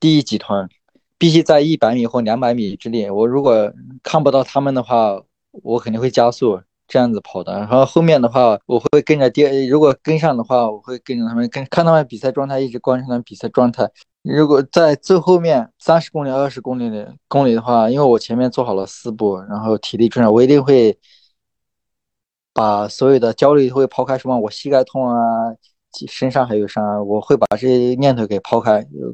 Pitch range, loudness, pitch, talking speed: 115-140 Hz, -16 LUFS, 125 Hz, 310 characters per minute